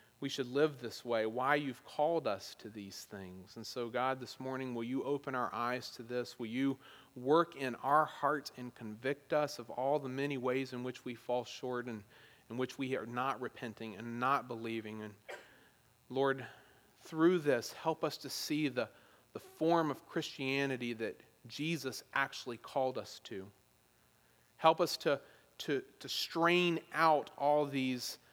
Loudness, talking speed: -36 LUFS, 170 wpm